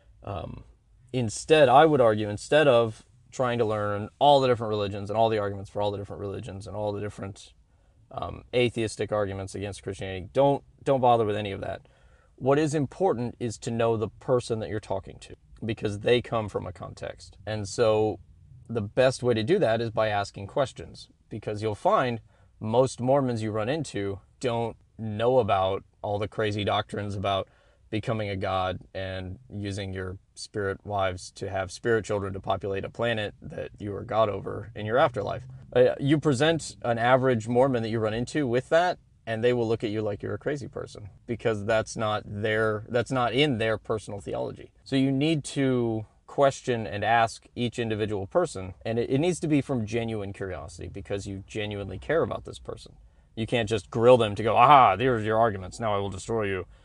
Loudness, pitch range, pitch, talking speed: -26 LUFS, 100-120 Hz, 110 Hz, 195 wpm